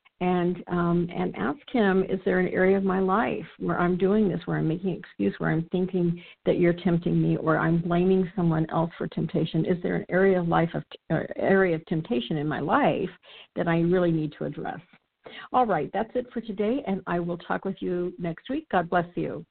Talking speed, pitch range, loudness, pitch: 220 wpm, 170-195 Hz, -26 LUFS, 180 Hz